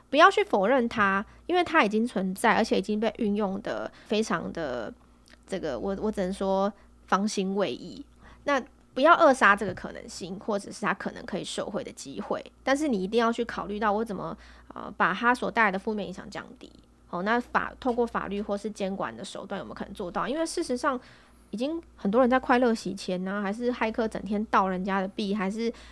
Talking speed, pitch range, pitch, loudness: 315 characters per minute, 195-245 Hz, 210 Hz, -27 LUFS